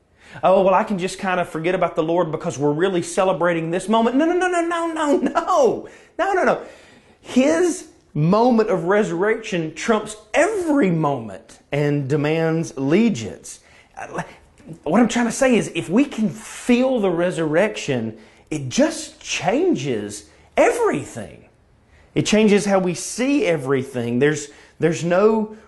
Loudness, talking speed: -20 LUFS, 145 wpm